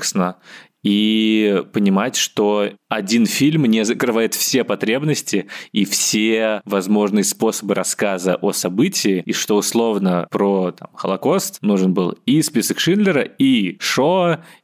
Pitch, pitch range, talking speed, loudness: 110 Hz, 100-130 Hz, 120 wpm, -18 LUFS